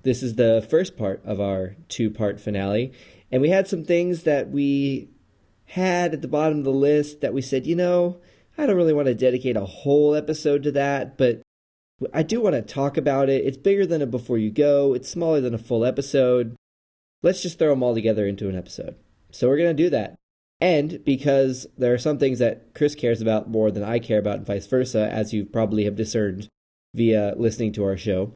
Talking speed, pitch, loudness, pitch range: 220 wpm, 125 Hz, -22 LUFS, 105-145 Hz